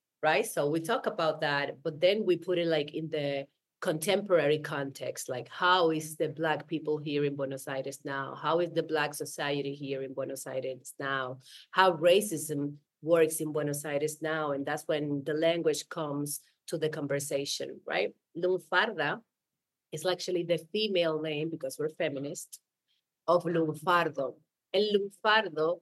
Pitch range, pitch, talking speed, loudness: 145-170 Hz, 155 Hz, 155 wpm, -31 LUFS